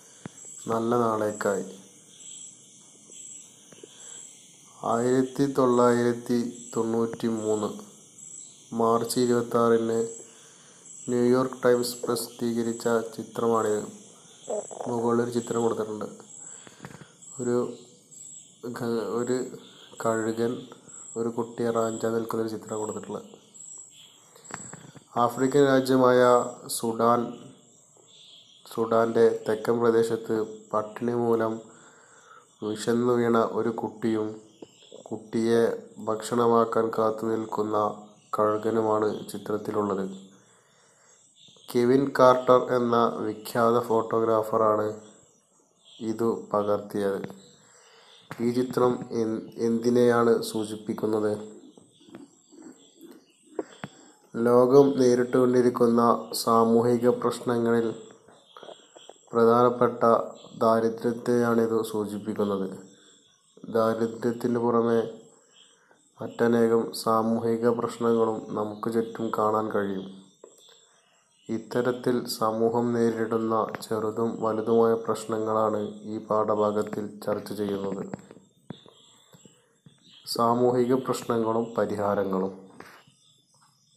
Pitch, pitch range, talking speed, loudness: 115 Hz, 110-120 Hz, 60 wpm, -25 LUFS